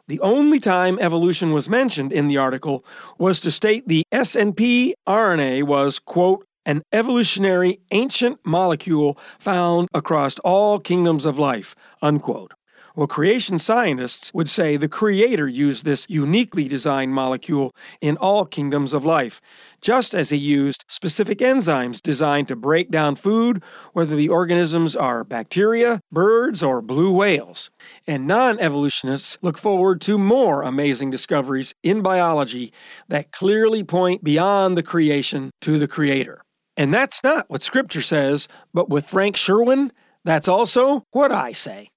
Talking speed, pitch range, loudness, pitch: 145 wpm, 145-205 Hz, -19 LUFS, 170 Hz